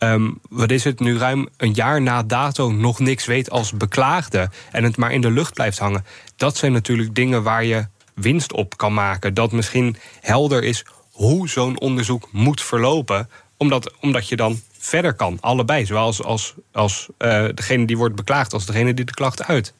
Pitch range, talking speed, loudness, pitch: 110-130 Hz, 195 wpm, -19 LUFS, 120 Hz